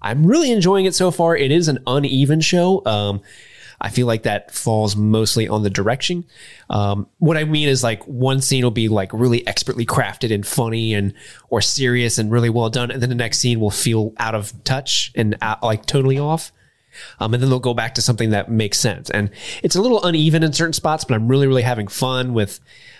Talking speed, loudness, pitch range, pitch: 220 wpm, -18 LUFS, 110-140 Hz, 125 Hz